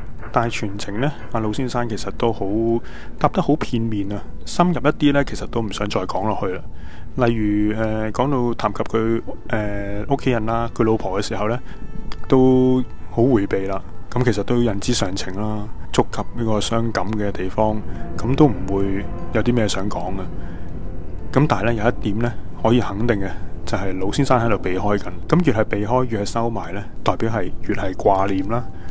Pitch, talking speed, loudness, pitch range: 110 Hz, 280 characters per minute, -21 LUFS, 100-120 Hz